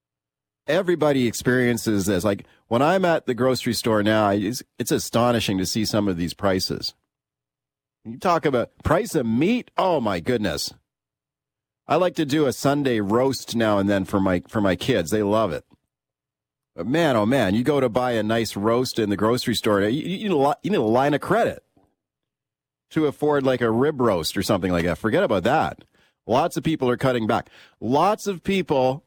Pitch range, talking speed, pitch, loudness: 105-140 Hz, 195 wpm, 120 Hz, -22 LUFS